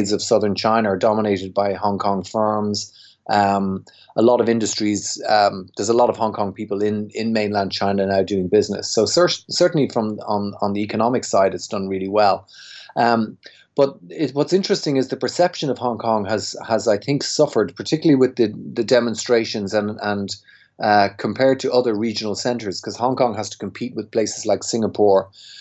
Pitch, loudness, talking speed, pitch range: 110 Hz, -20 LUFS, 190 wpm, 100-120 Hz